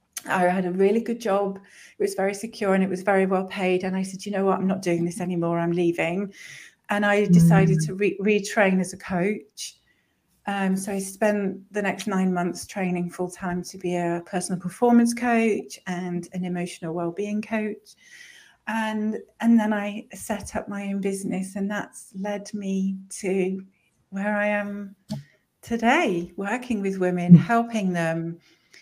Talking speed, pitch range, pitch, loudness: 175 wpm, 180-210 Hz, 195 Hz, -24 LUFS